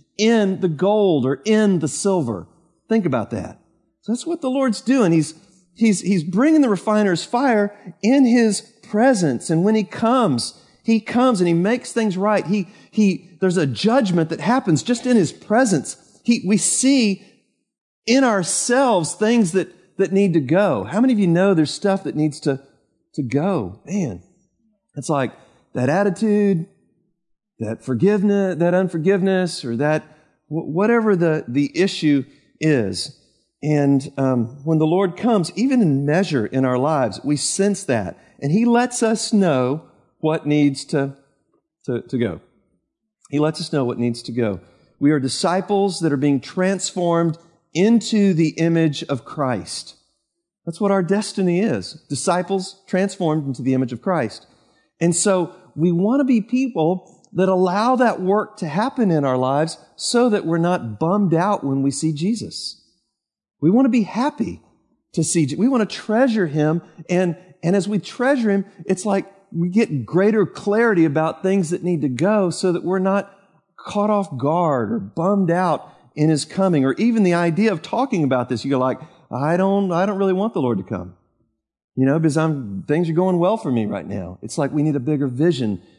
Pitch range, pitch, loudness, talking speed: 150-205 Hz, 180 Hz, -19 LUFS, 180 wpm